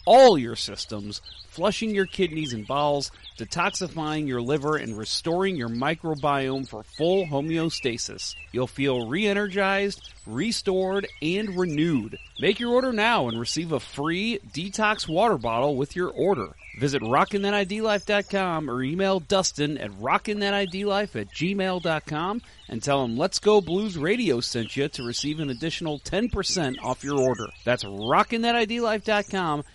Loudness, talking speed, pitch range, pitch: -25 LUFS, 135 wpm, 130-200 Hz, 160 Hz